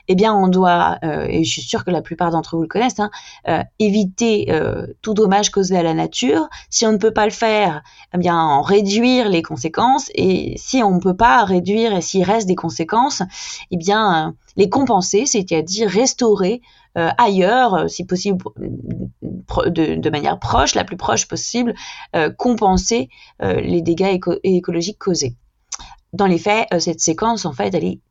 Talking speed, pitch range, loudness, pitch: 190 wpm, 170-215 Hz, -17 LUFS, 190 Hz